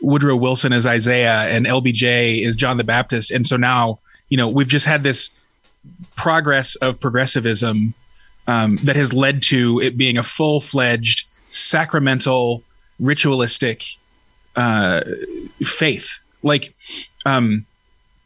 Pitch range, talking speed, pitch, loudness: 120-140 Hz, 125 wpm, 130 Hz, -16 LUFS